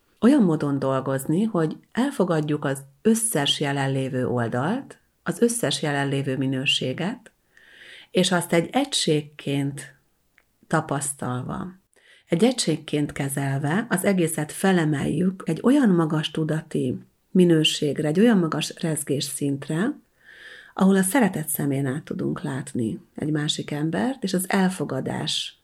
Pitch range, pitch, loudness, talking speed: 140-190 Hz, 155 Hz, -23 LUFS, 110 wpm